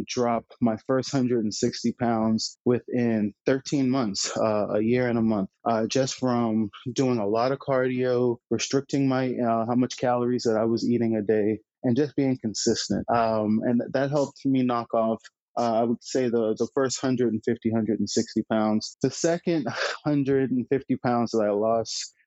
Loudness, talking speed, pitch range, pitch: -25 LUFS, 165 wpm, 110-130 Hz, 120 Hz